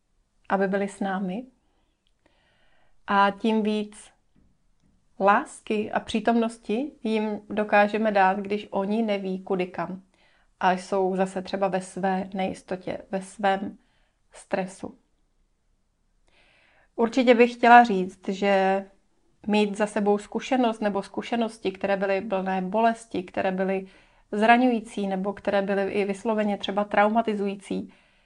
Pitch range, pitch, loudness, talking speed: 195-220 Hz, 200 Hz, -25 LUFS, 115 wpm